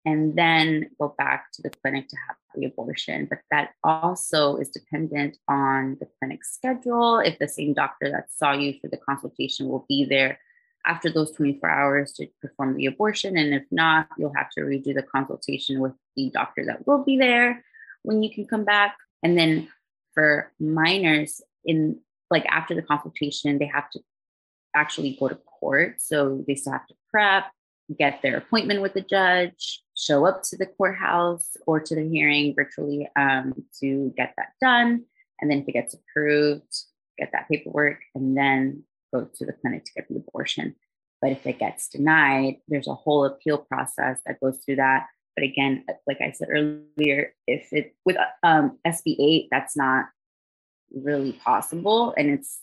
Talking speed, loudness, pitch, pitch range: 175 wpm, -23 LUFS, 150 Hz, 140-175 Hz